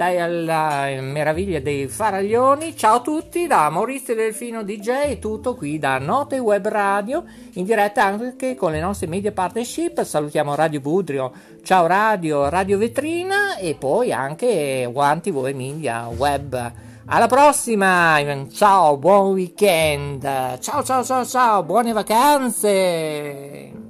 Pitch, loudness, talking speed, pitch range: 195 Hz, -19 LUFS, 130 wpm, 150-235 Hz